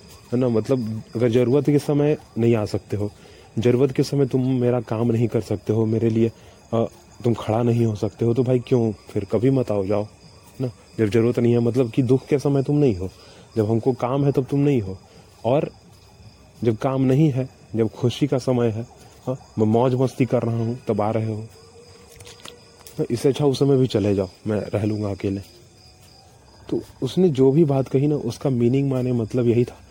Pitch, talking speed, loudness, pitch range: 120 Hz, 210 wpm, -21 LUFS, 105-130 Hz